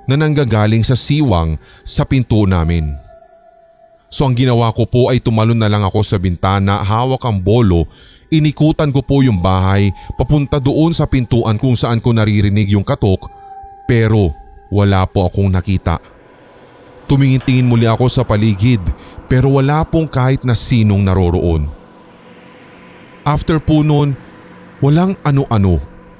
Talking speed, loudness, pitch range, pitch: 135 wpm, -14 LUFS, 100-140 Hz, 120 Hz